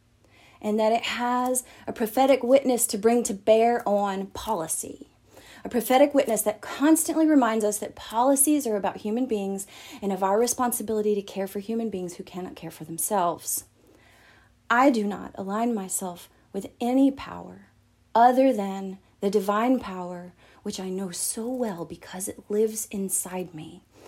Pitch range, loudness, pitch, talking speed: 190-240 Hz, -25 LUFS, 210 Hz, 155 wpm